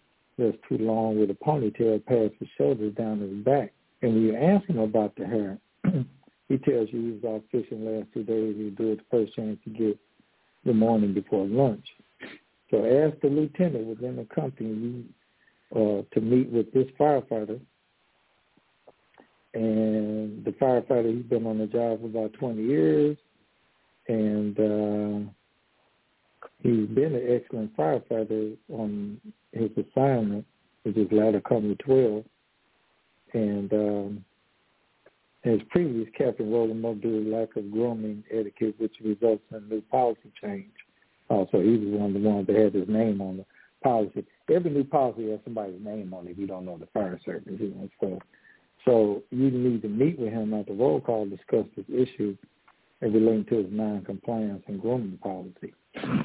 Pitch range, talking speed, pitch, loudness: 105-120 Hz, 165 wpm, 110 Hz, -27 LUFS